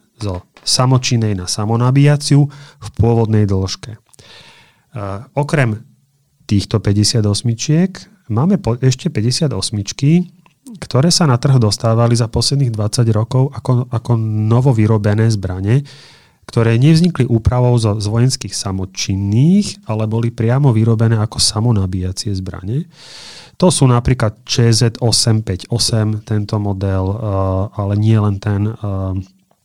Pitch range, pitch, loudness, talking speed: 105-130 Hz, 115 Hz, -15 LUFS, 115 wpm